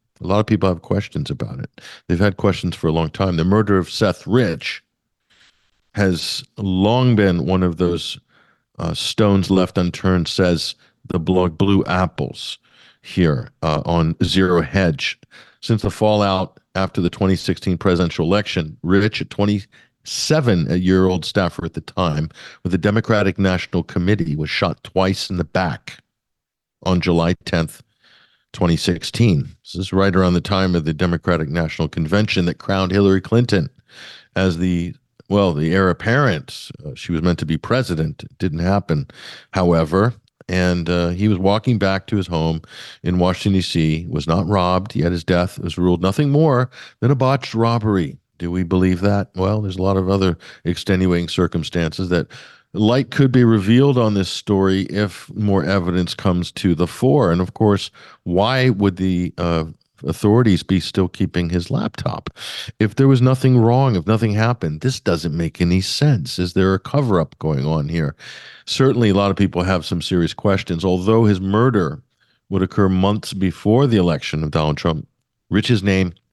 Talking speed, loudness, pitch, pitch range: 170 wpm, -18 LUFS, 95 Hz, 90-105 Hz